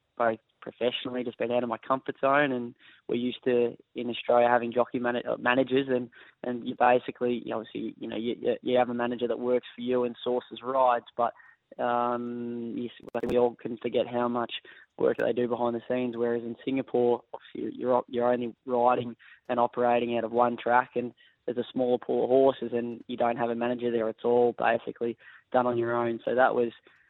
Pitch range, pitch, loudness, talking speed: 120-125 Hz, 120 Hz, -28 LUFS, 205 wpm